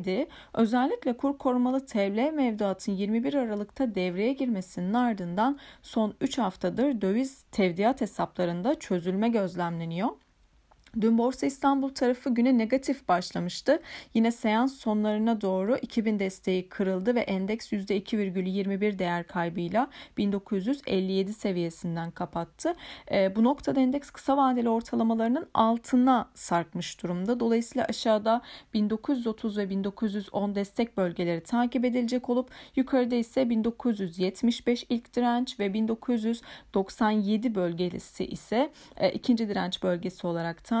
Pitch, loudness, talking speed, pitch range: 225 Hz, -28 LUFS, 110 wpm, 190-250 Hz